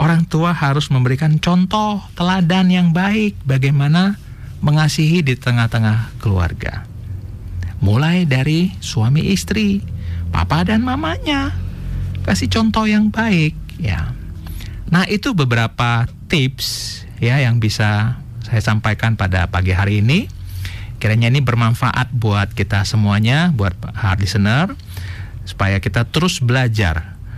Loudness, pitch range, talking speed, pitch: -17 LUFS, 100-155 Hz, 110 wpm, 115 Hz